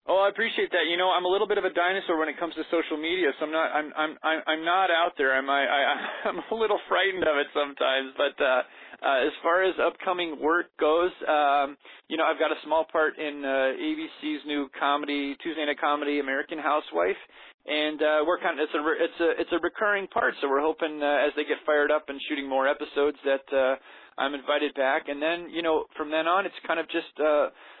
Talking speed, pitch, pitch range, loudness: 235 wpm, 155 Hz, 145-170 Hz, -26 LUFS